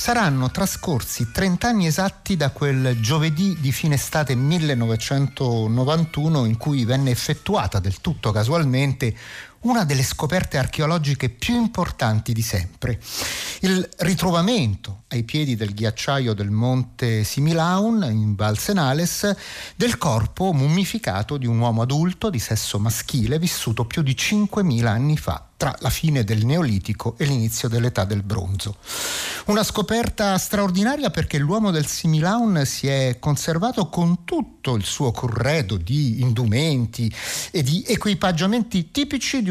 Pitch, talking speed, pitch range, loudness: 140 Hz, 130 wpm, 115-180 Hz, -21 LUFS